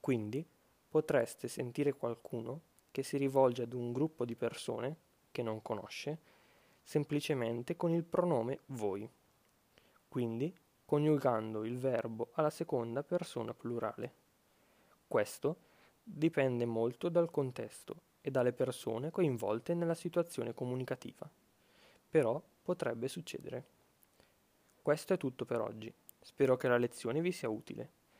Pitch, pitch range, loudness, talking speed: 135 Hz, 120-155 Hz, -37 LUFS, 115 wpm